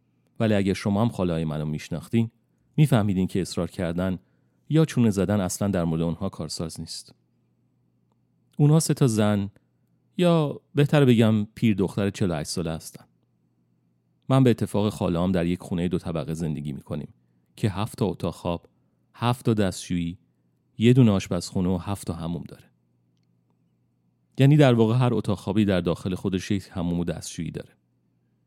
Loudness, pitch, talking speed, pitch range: -24 LUFS, 95 Hz, 155 wpm, 80-110 Hz